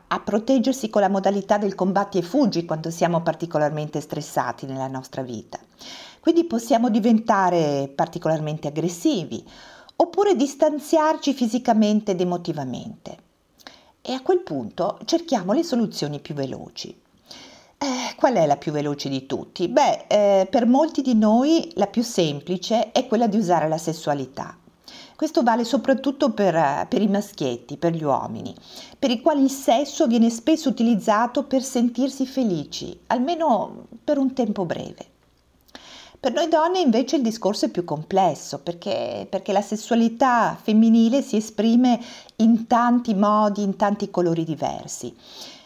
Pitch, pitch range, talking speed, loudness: 215 Hz, 170-260 Hz, 140 wpm, -22 LUFS